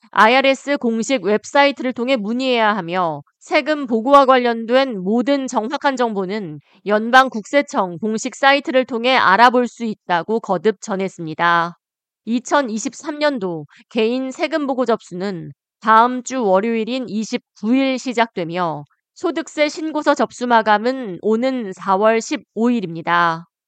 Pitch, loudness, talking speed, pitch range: 230 Hz, -18 LUFS, 260 characters per minute, 195-260 Hz